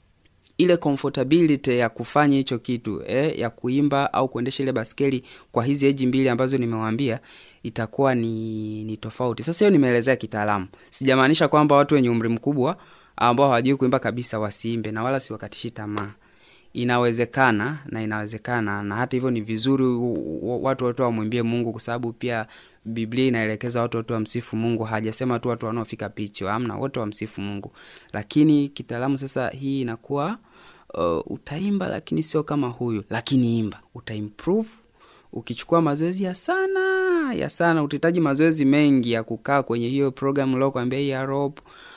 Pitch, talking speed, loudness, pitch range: 125 Hz, 145 wpm, -23 LUFS, 115-140 Hz